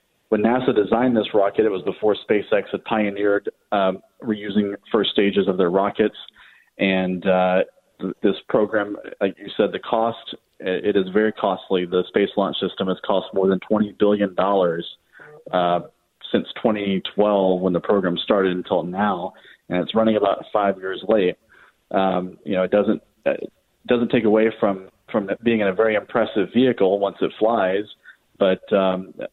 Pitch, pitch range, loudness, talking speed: 100 Hz, 95-110 Hz, -21 LUFS, 165 wpm